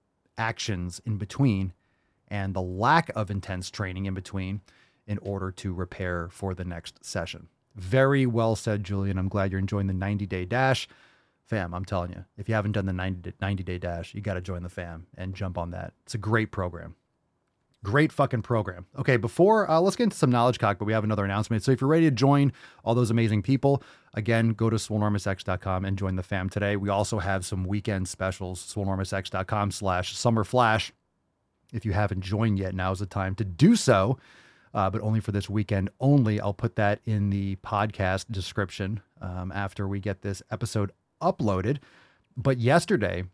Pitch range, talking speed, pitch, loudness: 95-115 Hz, 190 wpm, 100 Hz, -27 LUFS